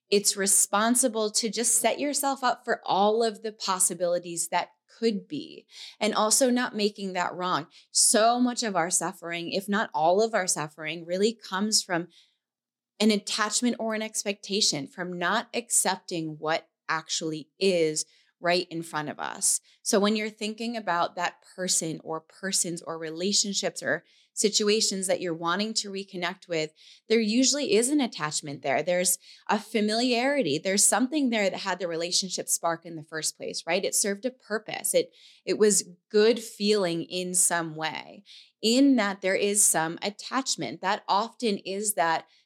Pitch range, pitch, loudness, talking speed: 175-225 Hz, 200 Hz, -26 LUFS, 160 wpm